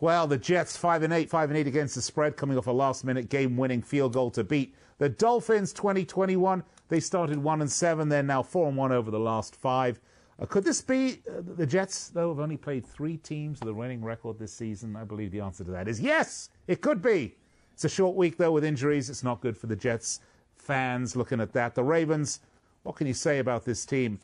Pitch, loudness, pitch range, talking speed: 140 Hz, -28 LUFS, 120-165 Hz, 240 wpm